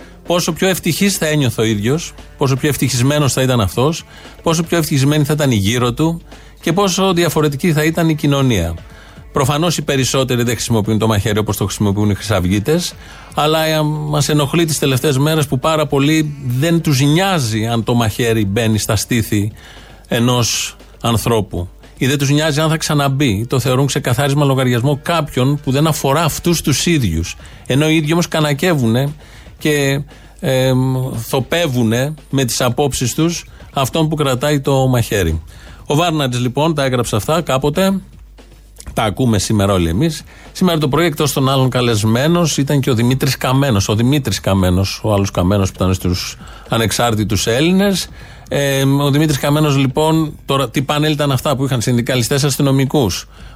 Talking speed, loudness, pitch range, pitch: 160 wpm, -15 LUFS, 115-155 Hz, 135 Hz